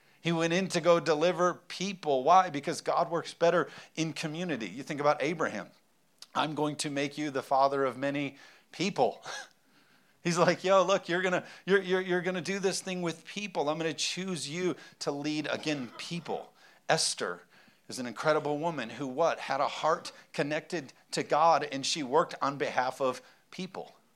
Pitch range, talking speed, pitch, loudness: 145-180 Hz, 175 wpm, 160 Hz, -30 LUFS